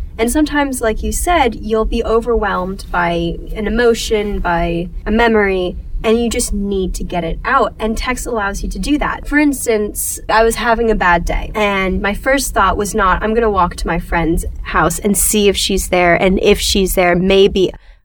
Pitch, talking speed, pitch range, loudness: 205 Hz, 200 wpm, 180-225 Hz, -15 LUFS